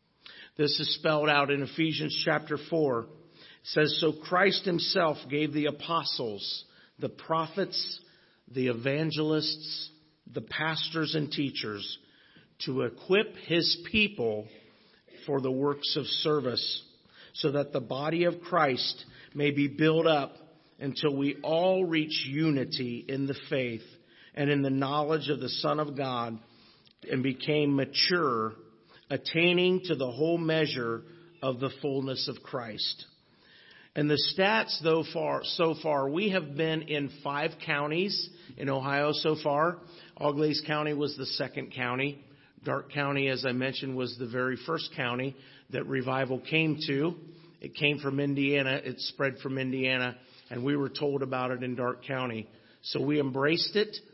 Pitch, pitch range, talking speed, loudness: 145 Hz, 130-160 Hz, 145 wpm, -29 LUFS